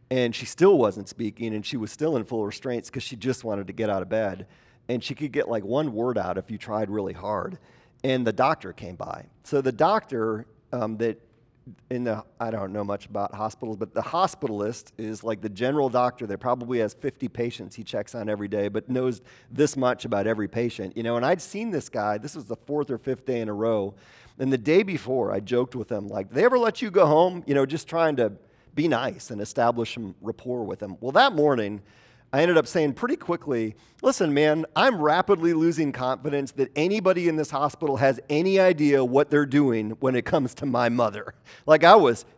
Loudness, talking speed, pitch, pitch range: -25 LUFS, 220 wpm, 125 Hz, 110-145 Hz